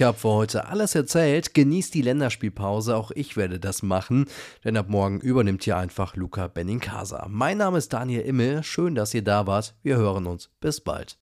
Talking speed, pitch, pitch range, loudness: 200 wpm, 110 Hz, 100-140 Hz, -25 LUFS